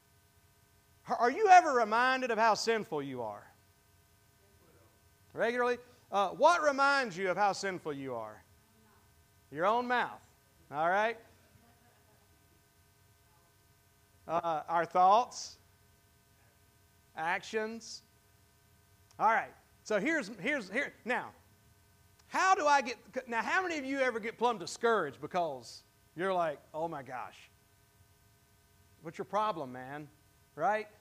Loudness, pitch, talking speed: -31 LUFS, 145 Hz, 115 wpm